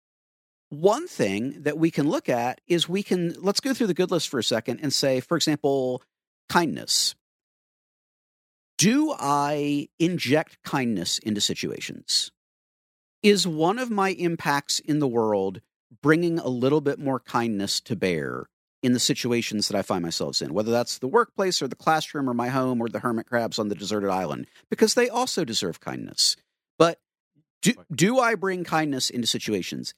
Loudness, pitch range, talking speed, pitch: -24 LUFS, 120-170 Hz, 170 wpm, 145 Hz